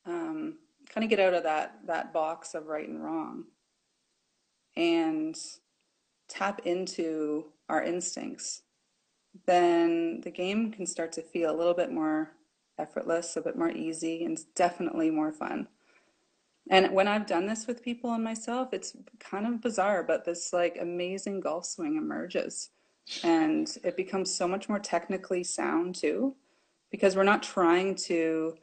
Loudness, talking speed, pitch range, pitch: -30 LUFS, 150 wpm, 170-245 Hz, 190 Hz